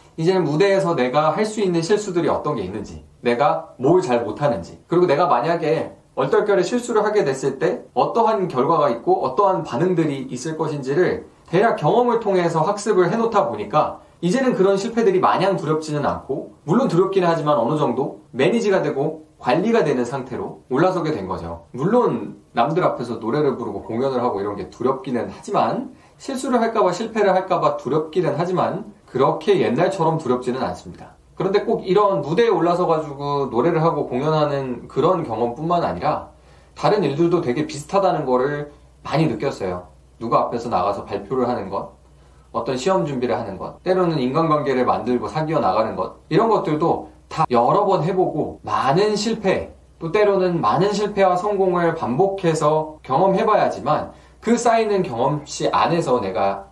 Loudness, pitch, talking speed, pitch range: -20 LUFS, 160 Hz, 370 characters per minute, 130-195 Hz